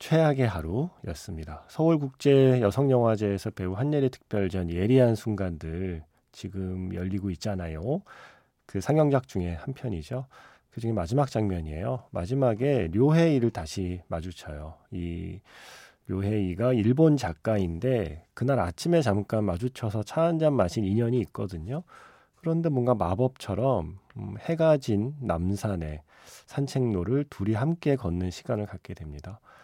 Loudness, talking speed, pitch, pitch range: -27 LUFS, 295 characters per minute, 110 Hz, 95-130 Hz